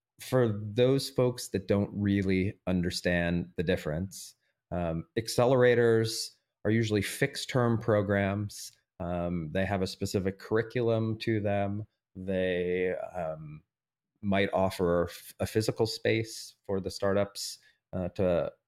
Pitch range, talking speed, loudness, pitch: 90-115 Hz, 115 wpm, -30 LUFS, 100 Hz